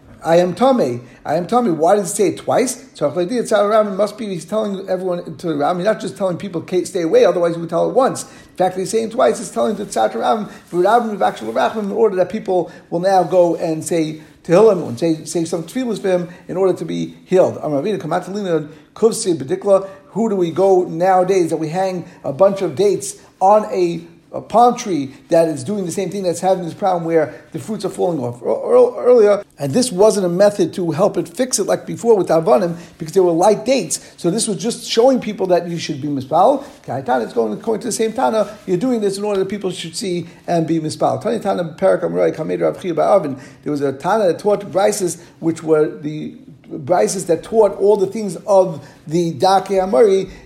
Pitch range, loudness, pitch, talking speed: 165-210 Hz, -17 LUFS, 185 Hz, 210 wpm